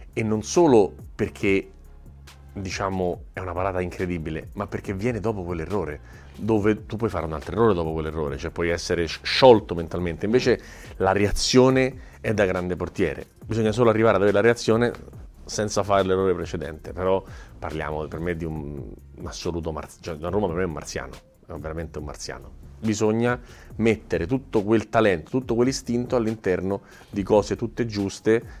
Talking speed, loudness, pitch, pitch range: 165 wpm, -24 LUFS, 95 Hz, 85-110 Hz